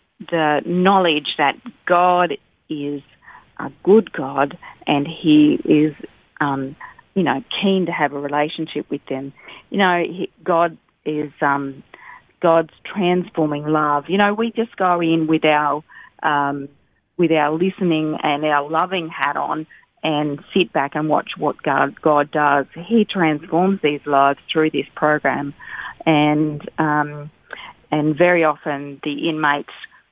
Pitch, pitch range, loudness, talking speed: 155 Hz, 145-175 Hz, -19 LUFS, 140 wpm